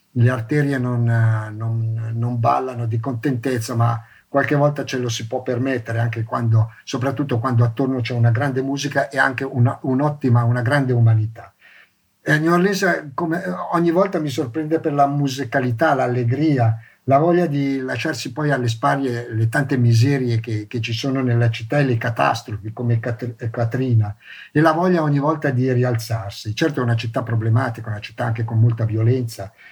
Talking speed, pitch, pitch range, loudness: 170 wpm, 125 Hz, 115-140 Hz, -20 LUFS